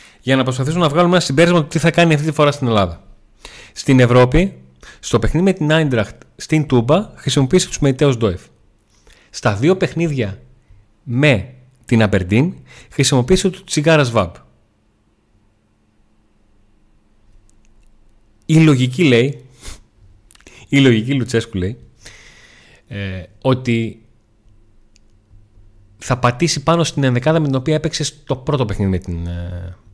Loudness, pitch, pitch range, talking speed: -16 LUFS, 120 Hz, 105-150 Hz, 125 wpm